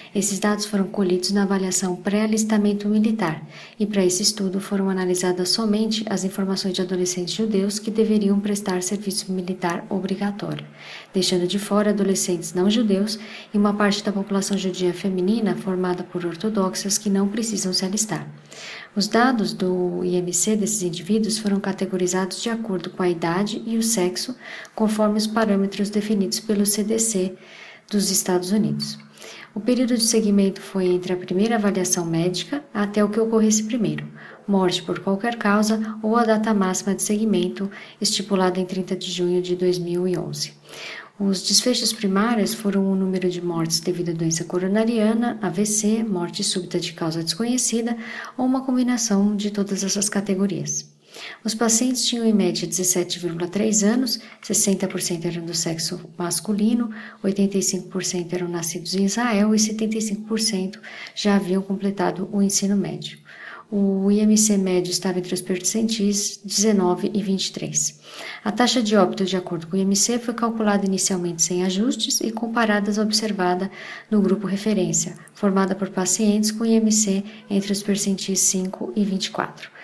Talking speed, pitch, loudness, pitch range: 145 wpm, 195 Hz, -22 LUFS, 185-215 Hz